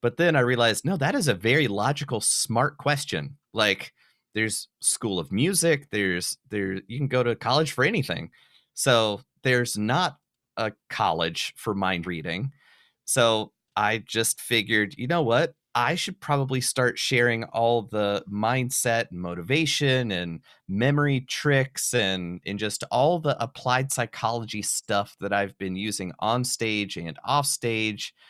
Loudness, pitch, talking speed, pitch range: -25 LUFS, 120 Hz, 150 wpm, 105-135 Hz